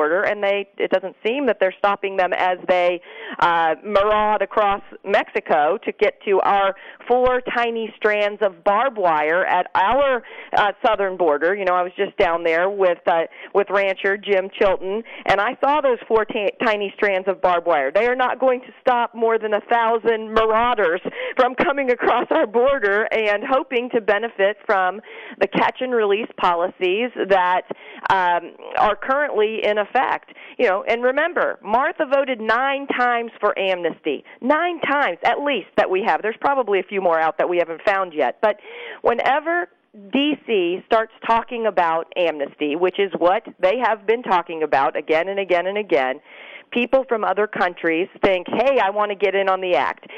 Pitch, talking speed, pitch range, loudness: 210 Hz, 175 wpm, 185-240 Hz, -20 LUFS